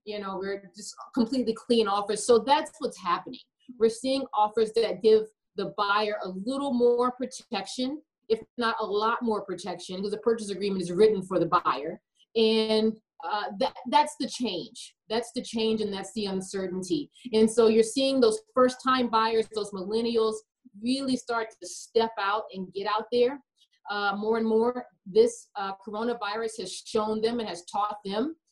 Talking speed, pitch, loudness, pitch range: 175 wpm, 225 Hz, -27 LUFS, 205-245 Hz